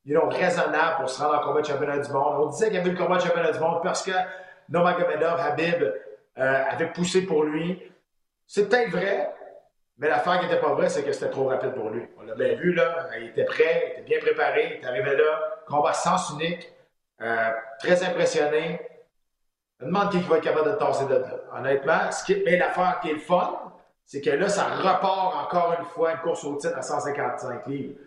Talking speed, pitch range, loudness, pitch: 230 wpm, 155-205 Hz, -25 LUFS, 175 Hz